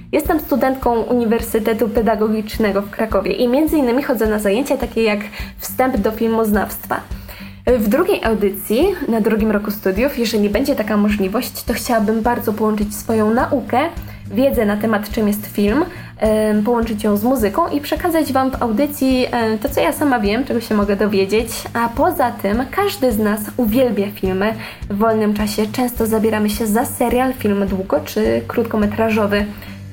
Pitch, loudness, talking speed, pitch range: 225 Hz, -17 LUFS, 155 wpm, 210-250 Hz